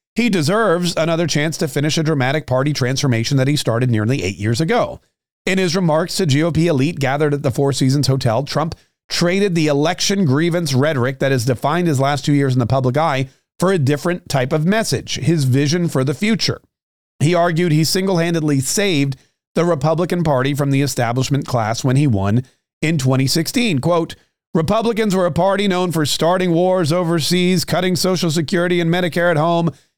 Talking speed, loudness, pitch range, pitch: 185 wpm, -17 LUFS, 135-175 Hz, 160 Hz